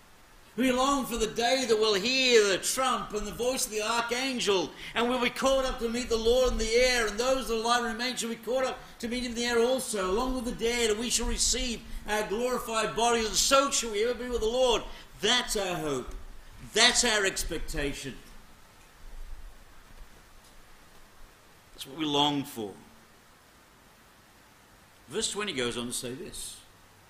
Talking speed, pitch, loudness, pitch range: 190 wpm, 225 Hz, -27 LUFS, 155-245 Hz